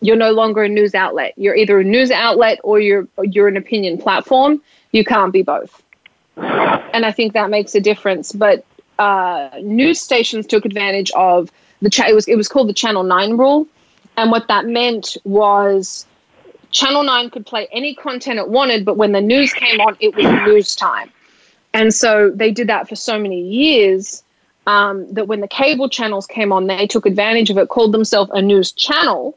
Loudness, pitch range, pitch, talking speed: -14 LUFS, 200-245 Hz, 220 Hz, 195 wpm